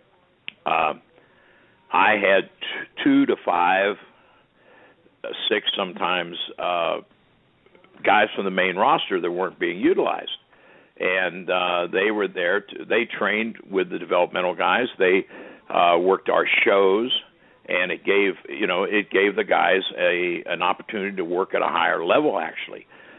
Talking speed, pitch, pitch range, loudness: 145 wpm, 395 Hz, 360-440 Hz, -22 LUFS